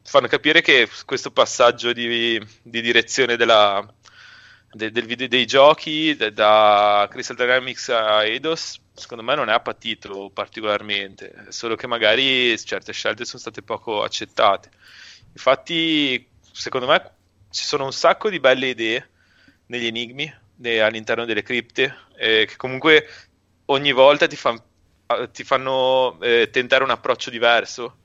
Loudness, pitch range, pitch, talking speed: -19 LUFS, 110-130 Hz, 120 Hz, 140 wpm